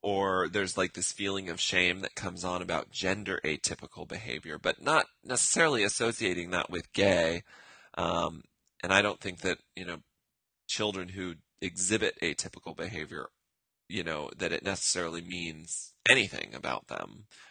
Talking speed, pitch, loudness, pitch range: 145 wpm, 90 Hz, -30 LUFS, 85-100 Hz